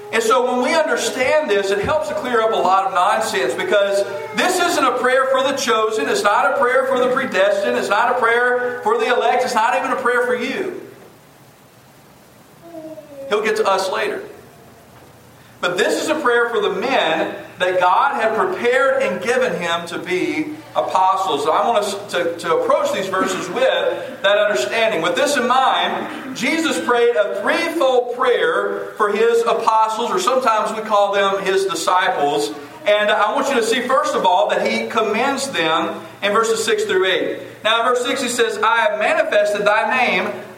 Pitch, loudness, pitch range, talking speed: 230 Hz, -17 LUFS, 200-265 Hz, 190 wpm